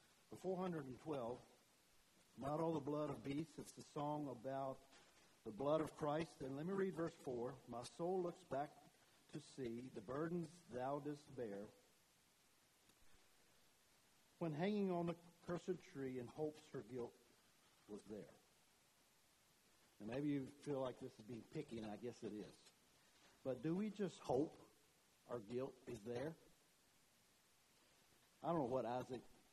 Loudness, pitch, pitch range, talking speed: -48 LUFS, 140 Hz, 125-160 Hz, 155 wpm